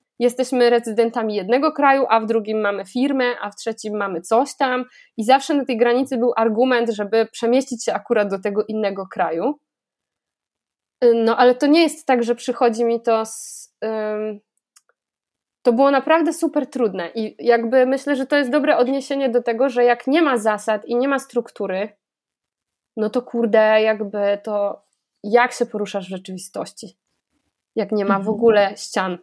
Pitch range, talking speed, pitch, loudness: 215-260 Hz, 170 wpm, 235 Hz, -19 LUFS